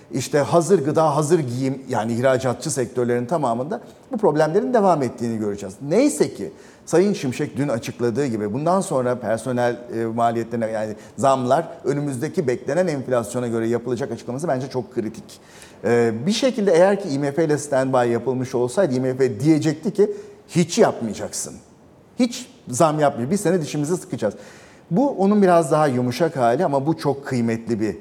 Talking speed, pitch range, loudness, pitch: 150 wpm, 120-170 Hz, -21 LUFS, 135 Hz